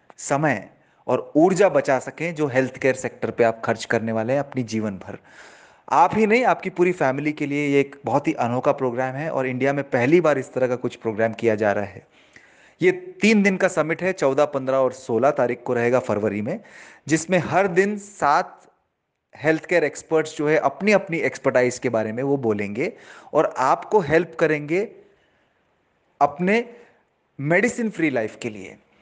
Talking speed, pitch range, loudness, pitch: 185 wpm, 125-170 Hz, -21 LUFS, 140 Hz